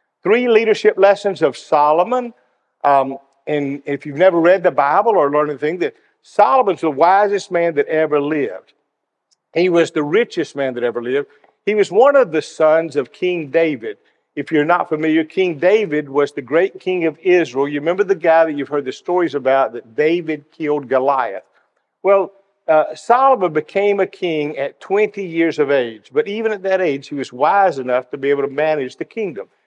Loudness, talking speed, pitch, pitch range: -17 LUFS, 190 wpm, 165 Hz, 145-200 Hz